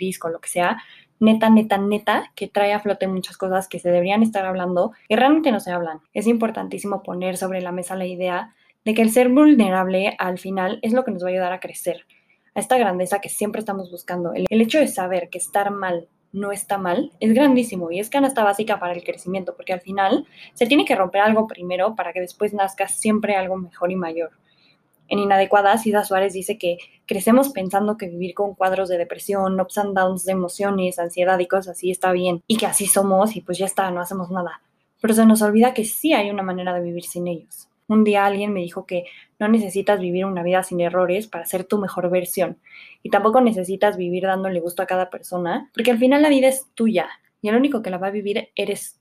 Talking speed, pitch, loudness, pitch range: 230 wpm, 195 Hz, -20 LUFS, 180-210 Hz